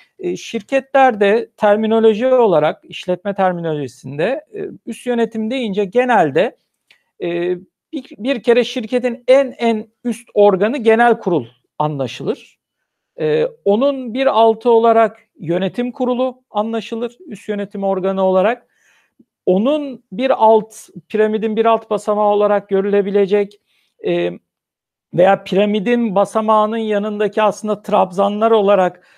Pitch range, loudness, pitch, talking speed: 200-240 Hz, -16 LUFS, 220 Hz, 95 wpm